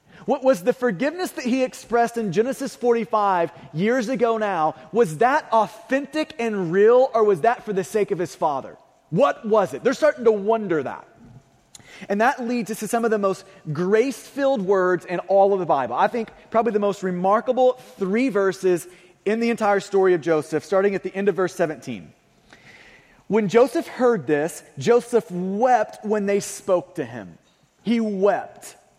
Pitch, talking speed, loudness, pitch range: 210 Hz, 180 wpm, -21 LUFS, 185-235 Hz